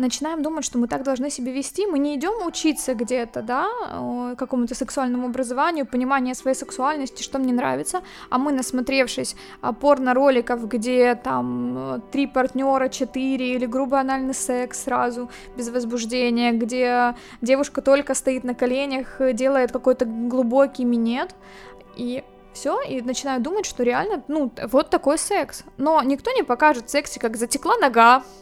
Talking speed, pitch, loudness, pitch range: 145 wpm, 260 Hz, -22 LUFS, 245-280 Hz